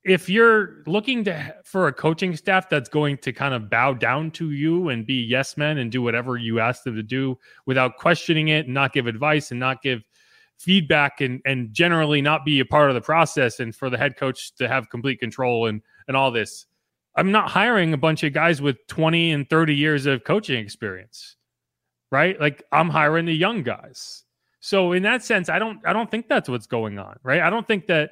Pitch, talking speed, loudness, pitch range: 150 Hz, 220 wpm, -21 LUFS, 130-175 Hz